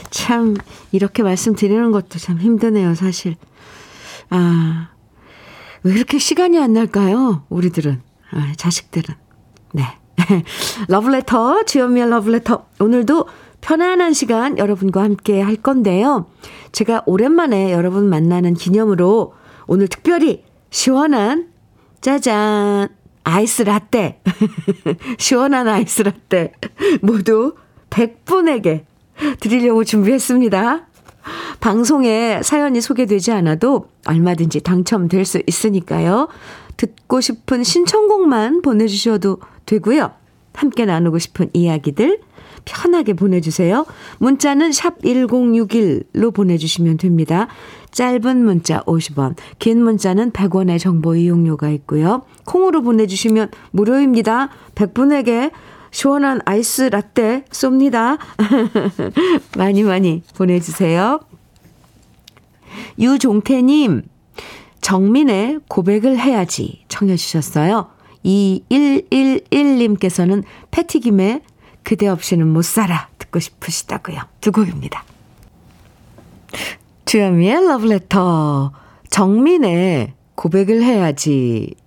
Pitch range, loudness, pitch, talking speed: 180-255 Hz, -15 LUFS, 210 Hz, 240 characters per minute